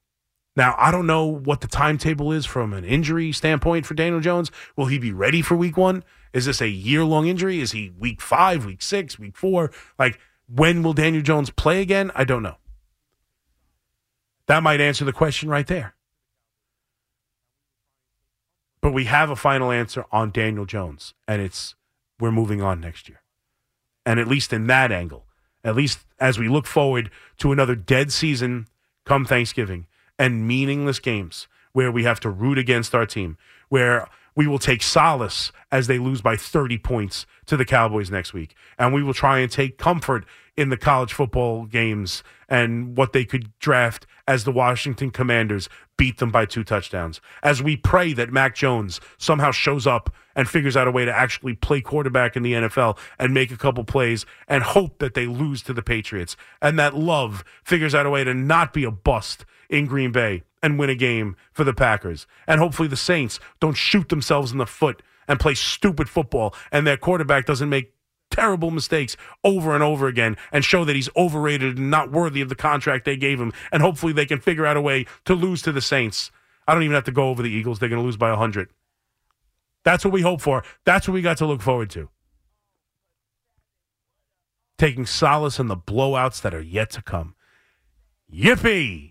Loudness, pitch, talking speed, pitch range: -21 LUFS, 130 Hz, 195 wpm, 115-150 Hz